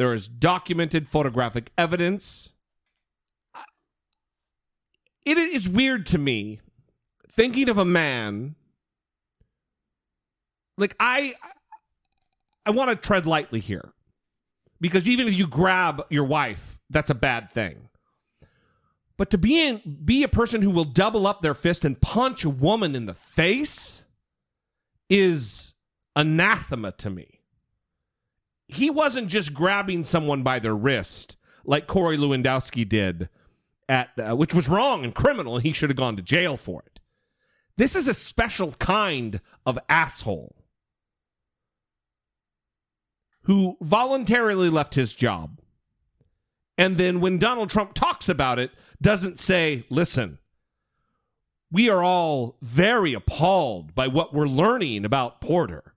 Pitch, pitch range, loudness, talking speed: 165 Hz, 130-205 Hz, -23 LUFS, 125 wpm